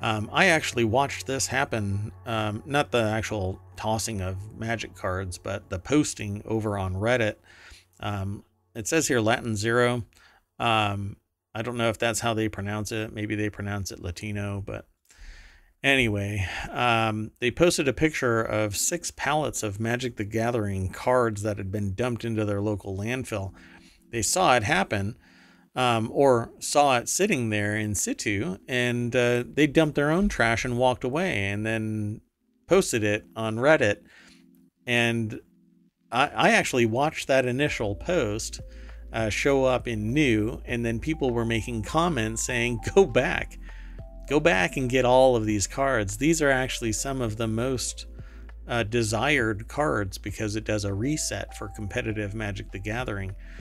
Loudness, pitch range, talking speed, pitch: -26 LUFS, 105-125 Hz, 160 wpm, 110 Hz